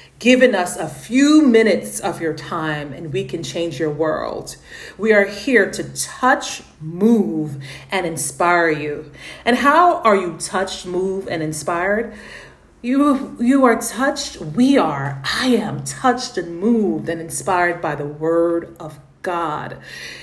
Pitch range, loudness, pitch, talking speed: 160-240 Hz, -18 LUFS, 180 Hz, 145 wpm